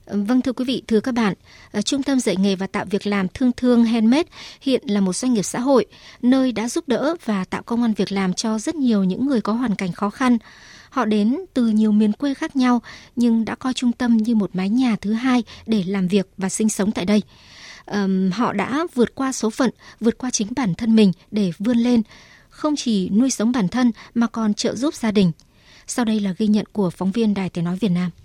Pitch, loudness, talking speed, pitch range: 225 Hz, -20 LUFS, 240 wpm, 200-250 Hz